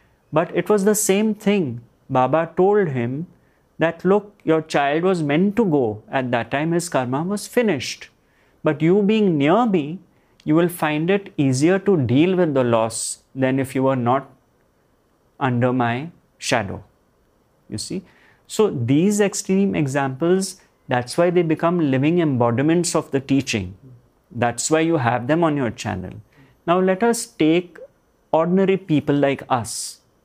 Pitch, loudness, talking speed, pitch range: 155 Hz, -20 LUFS, 155 wpm, 130-185 Hz